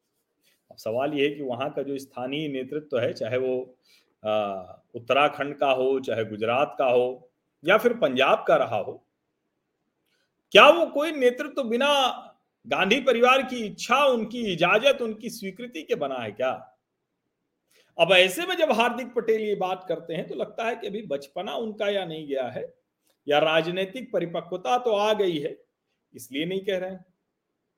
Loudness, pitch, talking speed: -24 LUFS, 195 Hz, 165 wpm